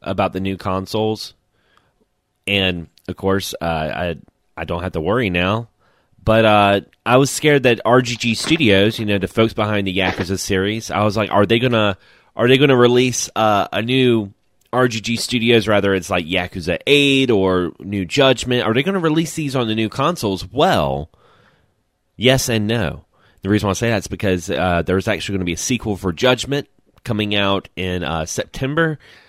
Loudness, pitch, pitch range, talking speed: -17 LUFS, 105 Hz, 95-120 Hz, 180 wpm